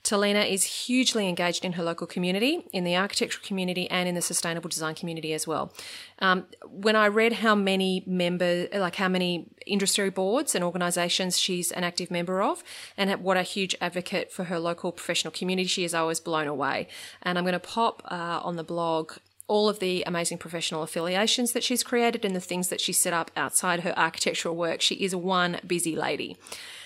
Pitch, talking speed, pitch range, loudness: 180 Hz, 200 wpm, 170-200 Hz, -26 LUFS